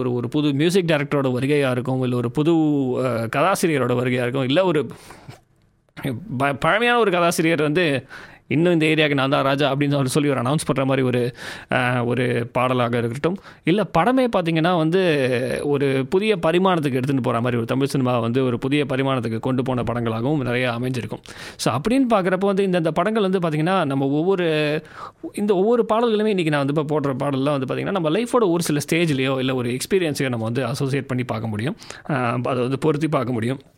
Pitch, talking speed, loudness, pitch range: 145 Hz, 175 wpm, -20 LUFS, 125-165 Hz